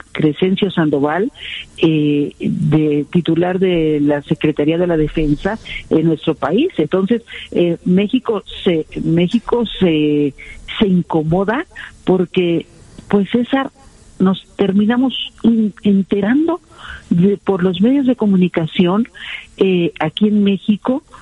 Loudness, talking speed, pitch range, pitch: -16 LUFS, 110 wpm, 160-215 Hz, 185 Hz